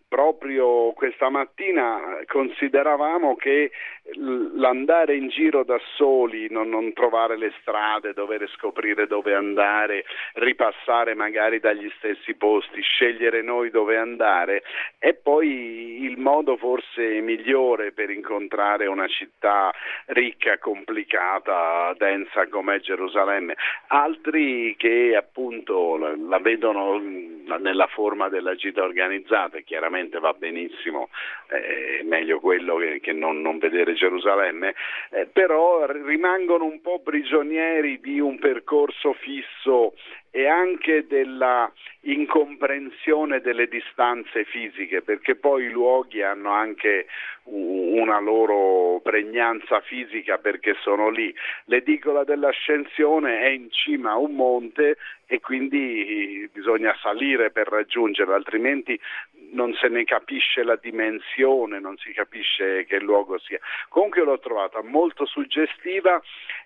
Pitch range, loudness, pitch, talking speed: 115-160 Hz, -22 LUFS, 135 Hz, 115 wpm